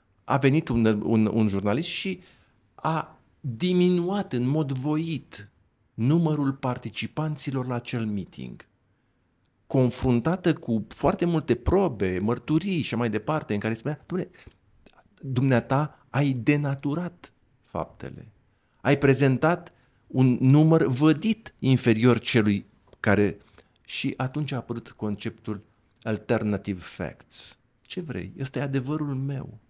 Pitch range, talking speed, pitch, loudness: 110-150 Hz, 110 wpm, 125 Hz, -25 LUFS